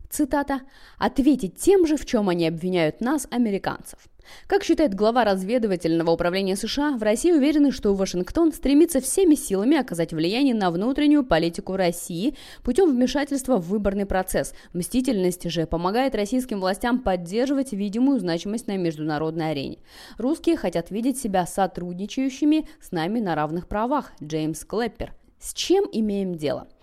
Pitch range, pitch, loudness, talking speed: 180-275 Hz, 215 Hz, -23 LUFS, 140 wpm